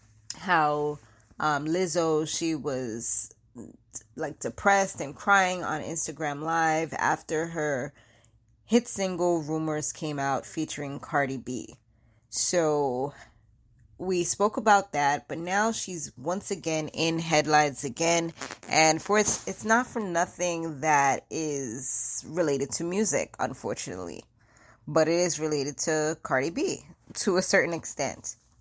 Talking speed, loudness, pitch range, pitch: 125 wpm, -27 LUFS, 135-170 Hz, 155 Hz